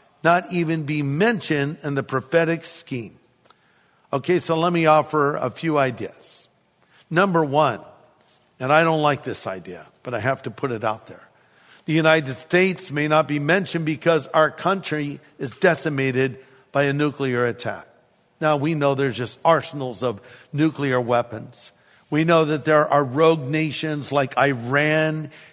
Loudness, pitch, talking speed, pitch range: -21 LUFS, 150 Hz, 155 wpm, 135-160 Hz